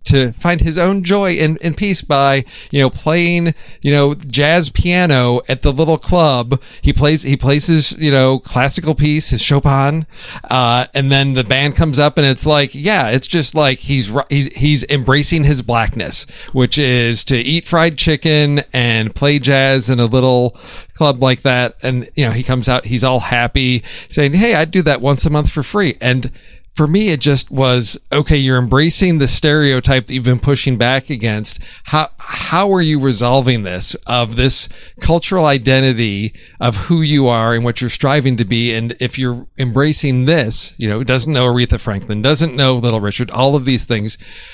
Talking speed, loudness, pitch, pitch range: 190 wpm, -13 LUFS, 135 Hz, 125-150 Hz